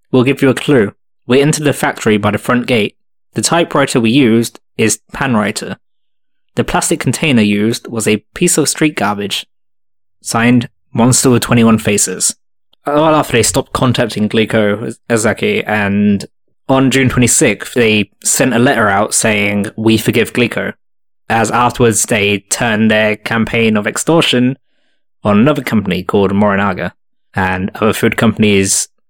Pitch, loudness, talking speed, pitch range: 115 Hz, -12 LUFS, 155 wpm, 105-130 Hz